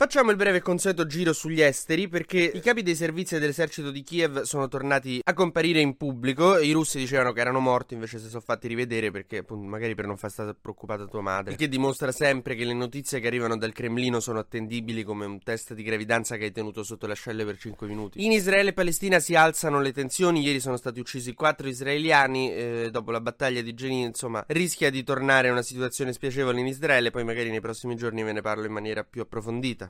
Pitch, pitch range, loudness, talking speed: 125 Hz, 115-150 Hz, -26 LUFS, 225 wpm